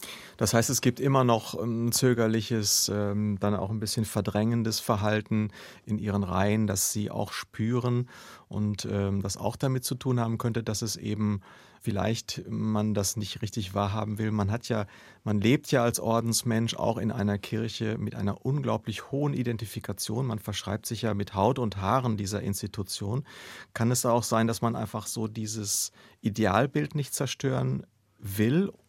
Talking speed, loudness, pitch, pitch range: 165 wpm, -28 LUFS, 110 Hz, 105-115 Hz